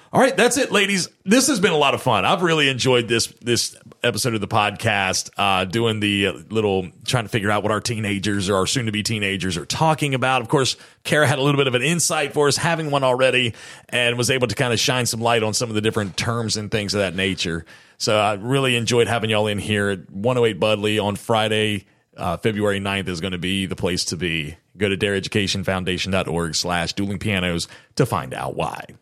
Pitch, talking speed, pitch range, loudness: 110 Hz, 225 wpm, 100-125 Hz, -20 LUFS